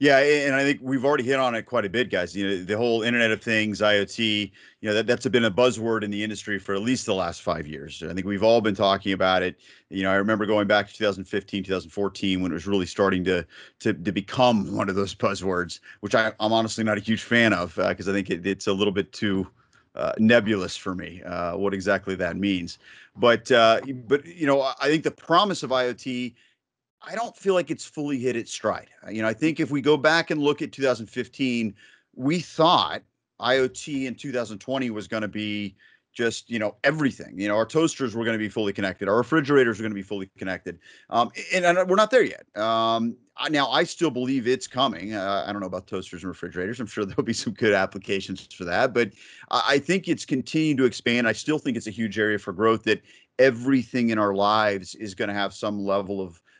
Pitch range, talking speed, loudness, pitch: 100-130 Hz, 235 wpm, -24 LUFS, 110 Hz